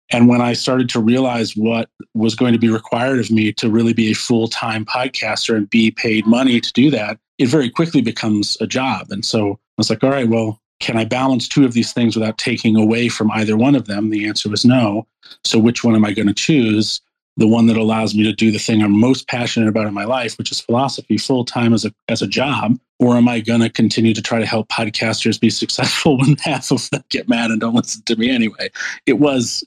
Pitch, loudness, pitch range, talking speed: 115 Hz, -16 LUFS, 110-120 Hz, 245 wpm